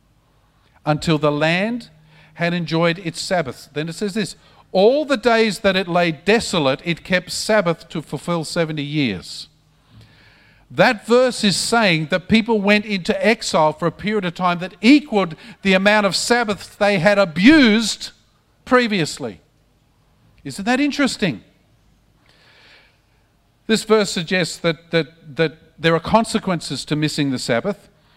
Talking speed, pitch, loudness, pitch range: 140 wpm, 180 Hz, -18 LUFS, 160-210 Hz